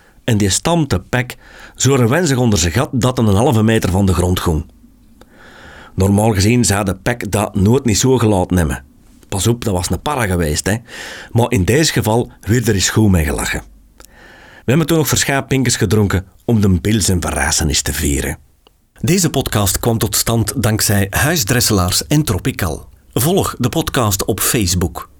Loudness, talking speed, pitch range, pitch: -15 LUFS, 175 wpm, 90-120 Hz, 105 Hz